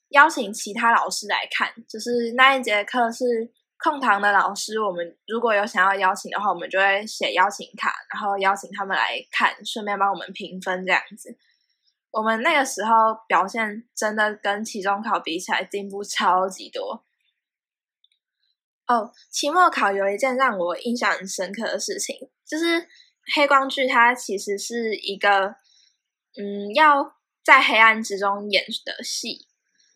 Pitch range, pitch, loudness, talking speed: 200-260 Hz, 220 Hz, -21 LUFS, 235 characters per minute